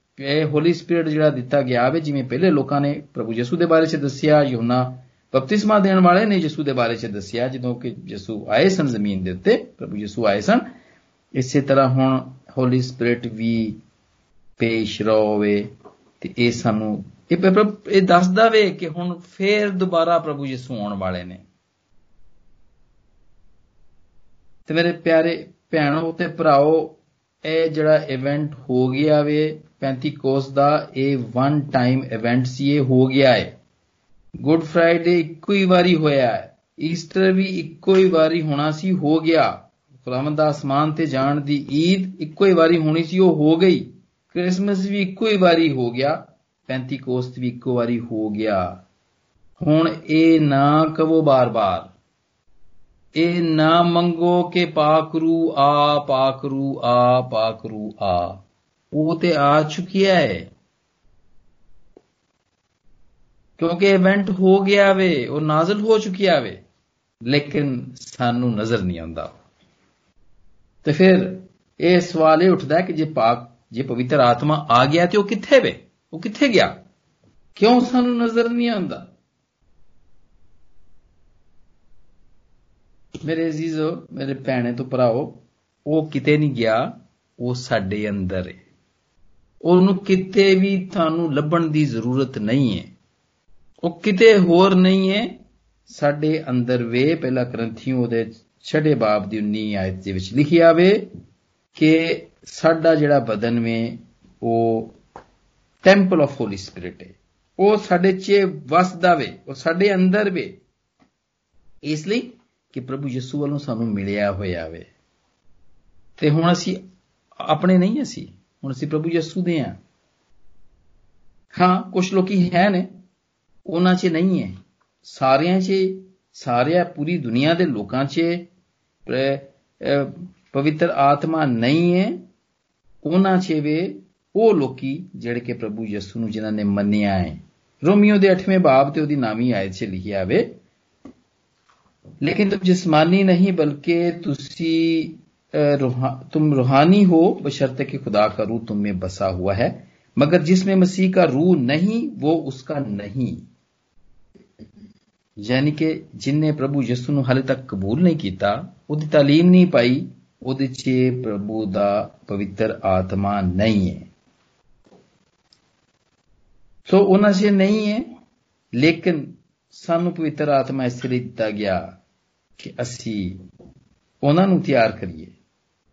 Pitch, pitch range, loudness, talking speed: 145 Hz, 115-170 Hz, -19 LUFS, 135 wpm